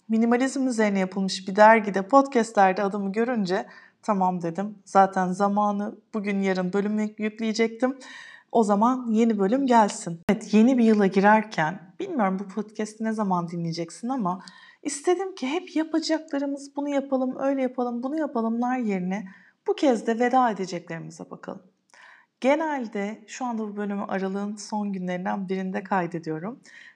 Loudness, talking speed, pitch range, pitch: -25 LUFS, 135 wpm, 195-255 Hz, 215 Hz